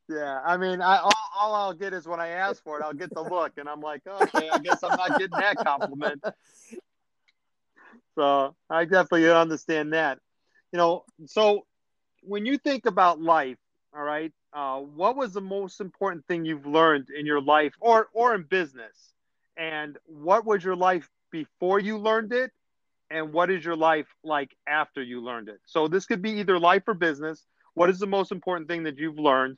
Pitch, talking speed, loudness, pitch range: 170 Hz, 195 wpm, -25 LUFS, 150-195 Hz